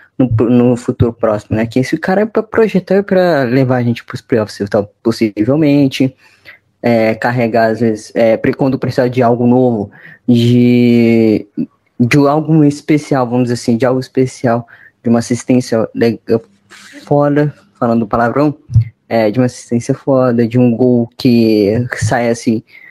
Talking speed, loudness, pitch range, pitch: 155 wpm, -13 LUFS, 115-135 Hz, 120 Hz